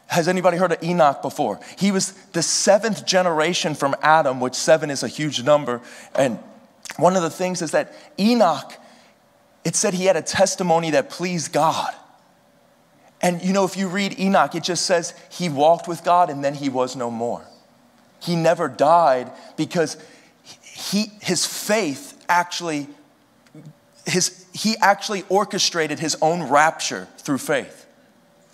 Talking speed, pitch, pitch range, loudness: 155 wpm, 175 Hz, 155-190 Hz, -20 LUFS